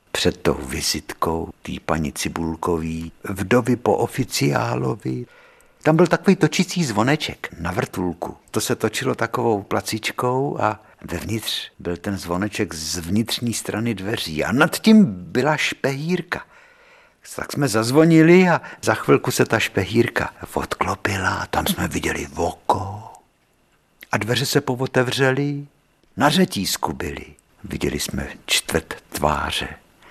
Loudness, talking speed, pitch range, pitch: -21 LUFS, 120 wpm, 100-145 Hz, 120 Hz